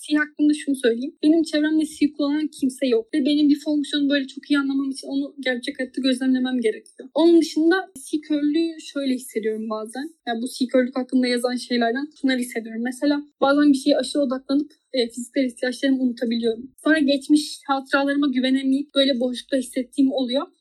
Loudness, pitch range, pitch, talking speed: -22 LUFS, 255-295 Hz, 275 Hz, 170 wpm